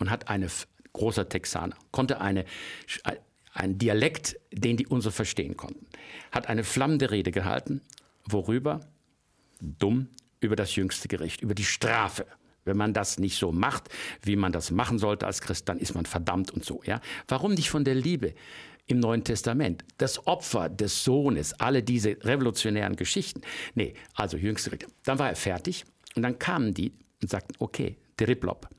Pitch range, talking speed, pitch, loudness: 95-125 Hz, 175 wpm, 105 Hz, -29 LUFS